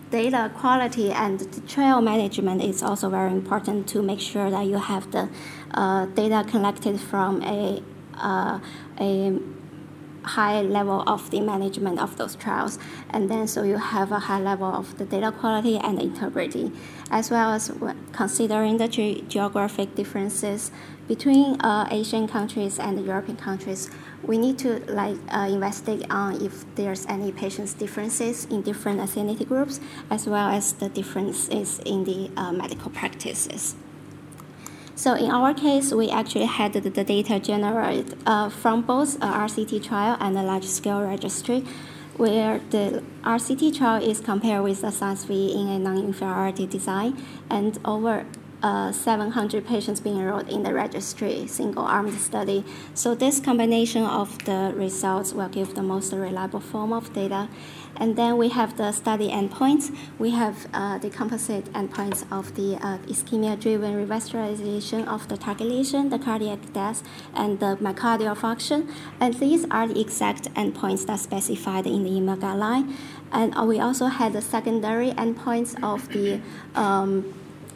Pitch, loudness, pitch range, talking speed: 210 Hz, -25 LUFS, 195-230 Hz, 155 wpm